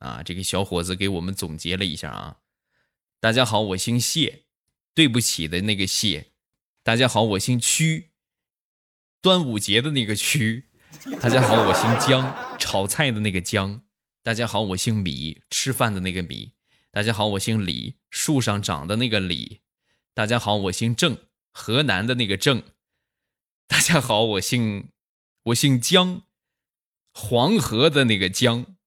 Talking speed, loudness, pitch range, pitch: 215 characters per minute, -21 LUFS, 95-125 Hz, 110 Hz